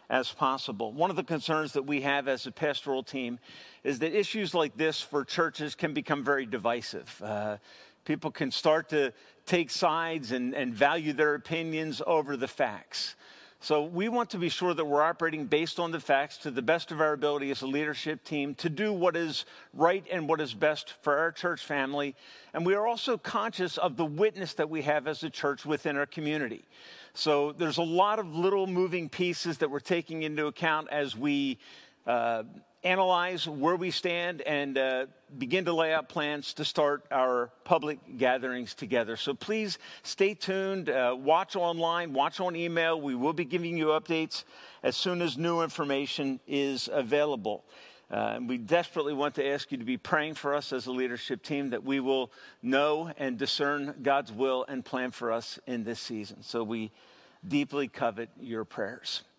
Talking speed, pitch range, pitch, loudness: 190 wpm, 140-170 Hz, 150 Hz, -30 LUFS